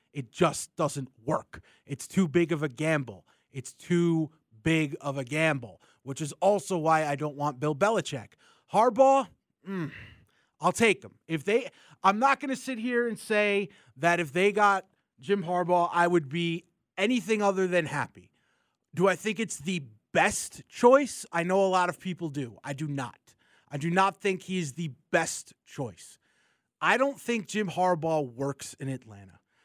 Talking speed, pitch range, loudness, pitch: 175 wpm, 145-195 Hz, -28 LUFS, 170 Hz